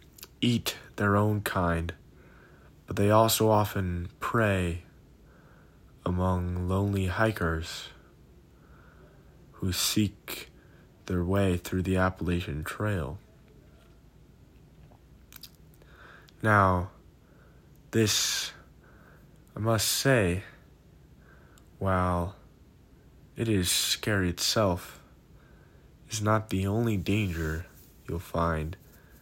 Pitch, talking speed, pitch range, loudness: 95 Hz, 75 wpm, 85-105 Hz, -28 LUFS